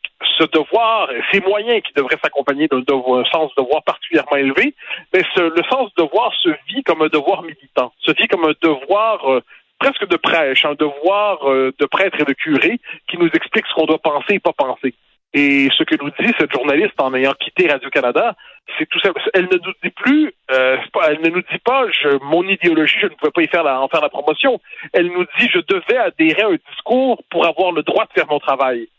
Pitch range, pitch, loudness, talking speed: 145-205 Hz, 165 Hz, -16 LUFS, 225 wpm